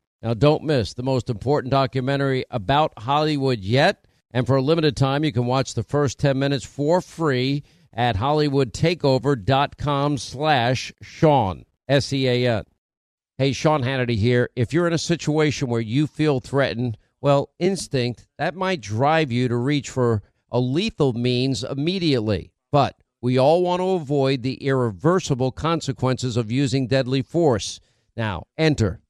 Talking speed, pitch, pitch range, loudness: 145 wpm, 135 Hz, 125-150 Hz, -22 LUFS